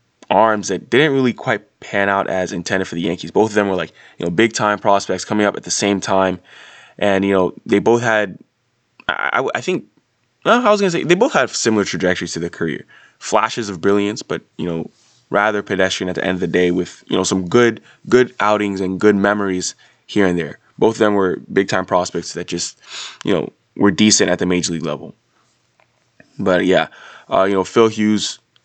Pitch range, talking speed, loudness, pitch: 90-110 Hz, 215 wpm, -17 LUFS, 100 Hz